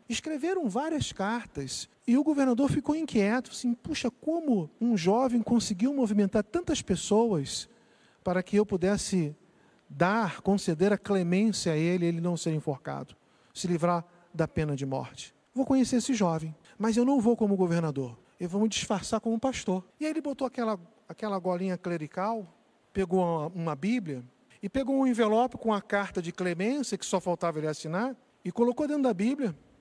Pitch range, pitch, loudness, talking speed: 175-245 Hz, 205 Hz, -29 LUFS, 170 wpm